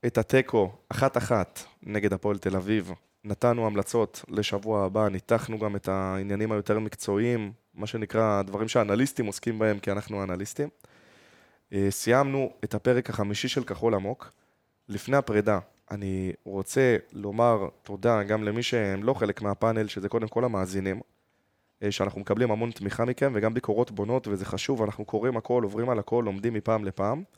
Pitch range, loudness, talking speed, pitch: 100-120 Hz, -28 LUFS, 150 wpm, 105 Hz